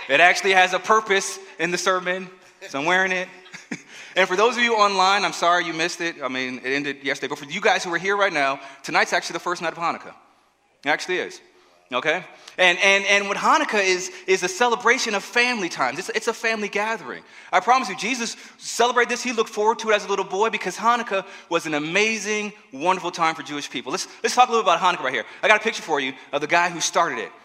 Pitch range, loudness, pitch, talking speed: 175-220 Hz, -21 LUFS, 190 Hz, 245 wpm